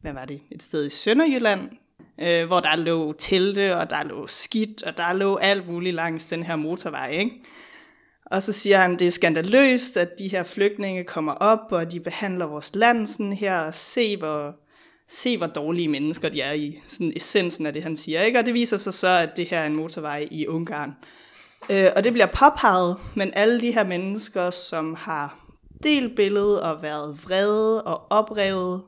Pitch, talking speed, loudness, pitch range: 185 Hz, 195 wpm, -22 LUFS, 160-215 Hz